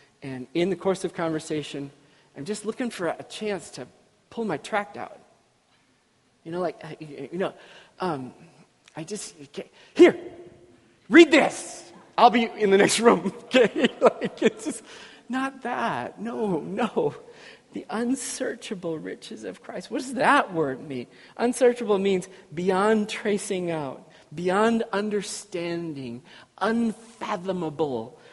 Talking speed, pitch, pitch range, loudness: 125 wpm, 205 Hz, 165-235 Hz, -24 LUFS